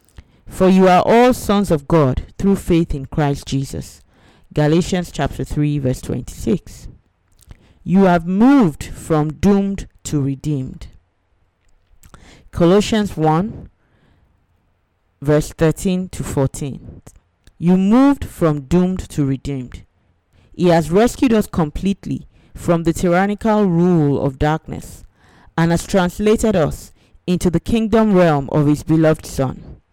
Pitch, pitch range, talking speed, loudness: 160 Hz, 135-185 Hz, 120 wpm, -17 LUFS